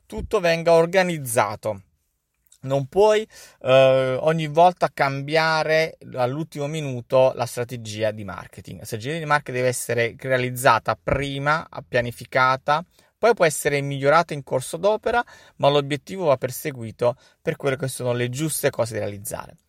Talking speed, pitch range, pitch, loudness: 135 wpm, 125-160 Hz, 140 Hz, -22 LUFS